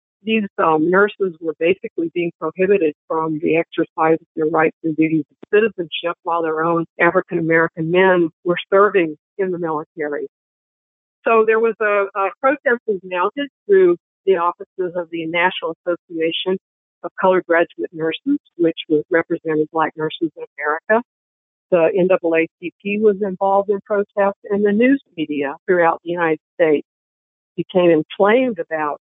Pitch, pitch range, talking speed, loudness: 175 Hz, 160-205 Hz, 145 wpm, -18 LUFS